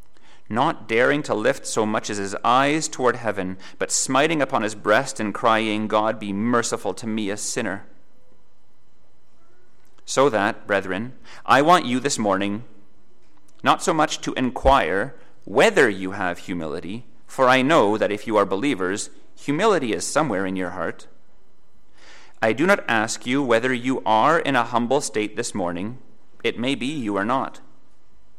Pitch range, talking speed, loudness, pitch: 100-125 Hz, 160 wpm, -21 LUFS, 110 Hz